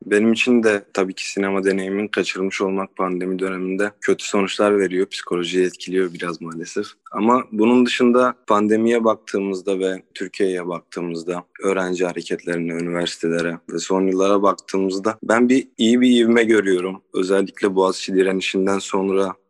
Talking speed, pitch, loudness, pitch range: 130 wpm, 95 Hz, -20 LUFS, 90-105 Hz